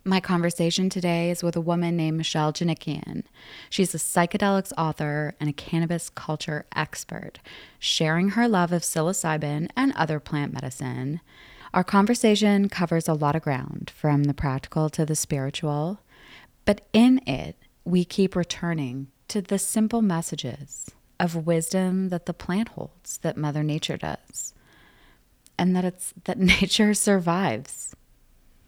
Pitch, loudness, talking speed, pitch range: 170 Hz, -25 LUFS, 140 wpm, 150-190 Hz